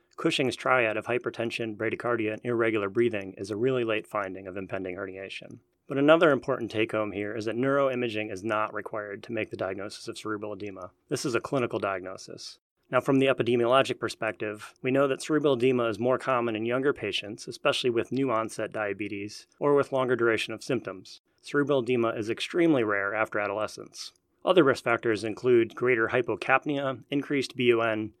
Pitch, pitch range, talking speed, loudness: 115 Hz, 110-130 Hz, 175 wpm, -27 LUFS